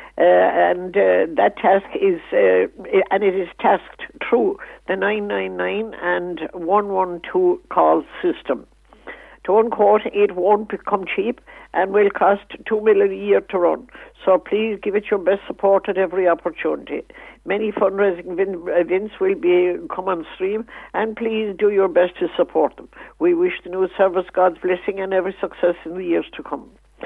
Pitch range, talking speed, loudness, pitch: 185-220 Hz, 165 wpm, -19 LUFS, 200 Hz